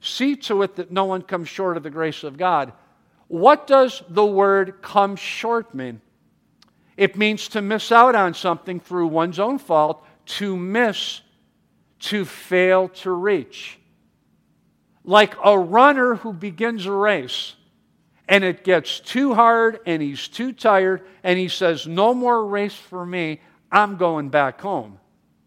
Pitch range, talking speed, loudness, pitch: 175-220 Hz, 155 wpm, -19 LUFS, 195 Hz